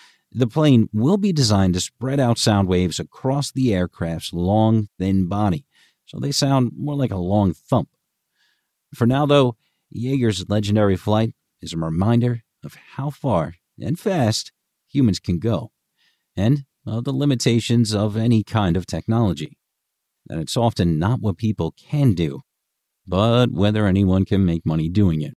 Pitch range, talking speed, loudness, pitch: 95-130 Hz, 160 wpm, -20 LUFS, 110 Hz